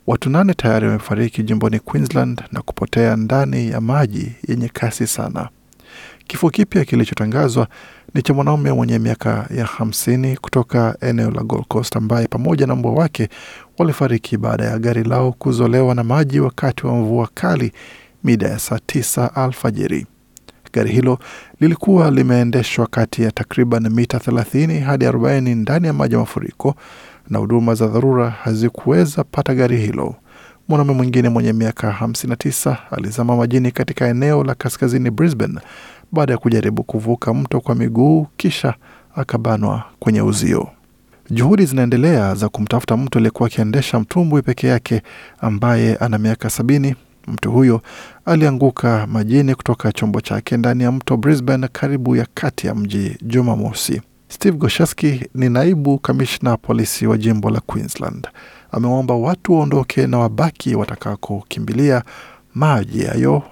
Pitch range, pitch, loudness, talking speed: 115-135 Hz, 120 Hz, -17 LUFS, 135 wpm